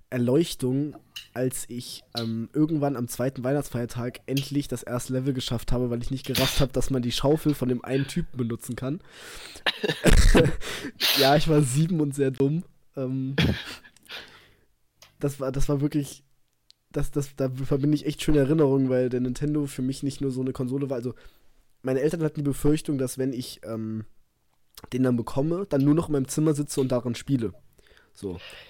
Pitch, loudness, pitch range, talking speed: 135 Hz, -26 LUFS, 125-145 Hz, 180 wpm